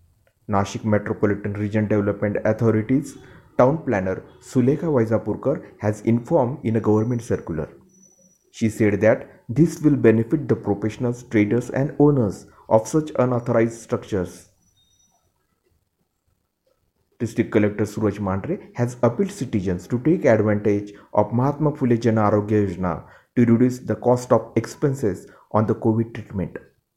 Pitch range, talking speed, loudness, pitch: 105-125 Hz, 120 wpm, -21 LUFS, 110 Hz